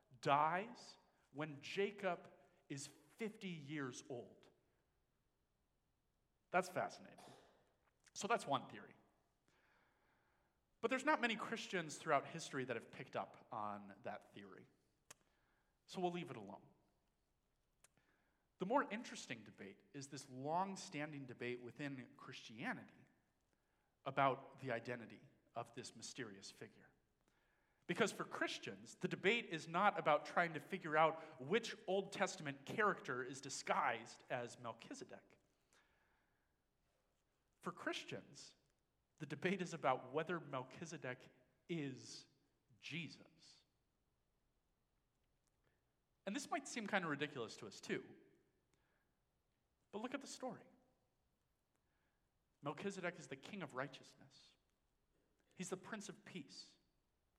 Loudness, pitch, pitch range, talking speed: -45 LUFS, 155 Hz, 135-185 Hz, 110 wpm